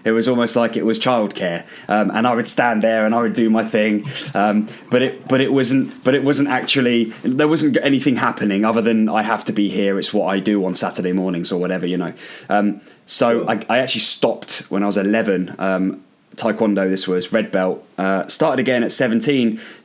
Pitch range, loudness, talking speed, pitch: 95-115 Hz, -18 LUFS, 220 wpm, 110 Hz